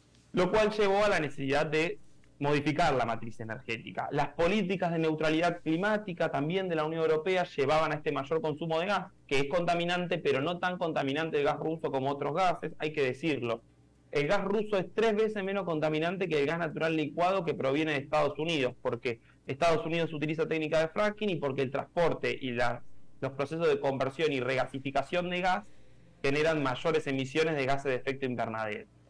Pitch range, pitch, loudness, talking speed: 140-175 Hz, 155 Hz, -31 LUFS, 190 wpm